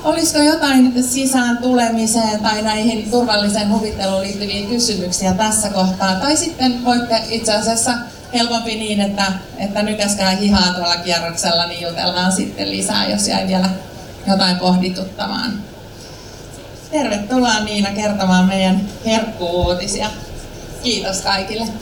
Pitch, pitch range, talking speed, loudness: 205 Hz, 185-230 Hz, 115 wpm, -16 LUFS